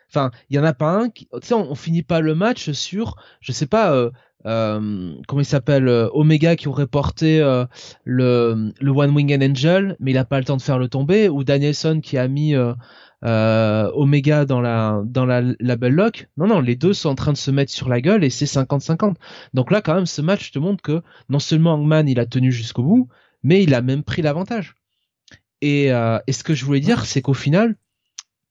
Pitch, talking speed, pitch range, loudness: 140 Hz, 235 wpm, 125-160 Hz, -18 LUFS